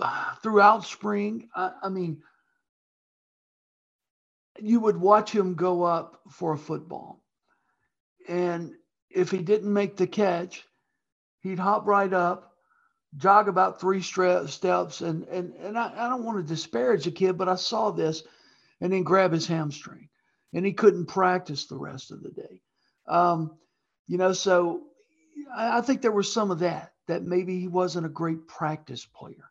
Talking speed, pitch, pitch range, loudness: 160 wpm, 185 Hz, 175-210 Hz, -25 LUFS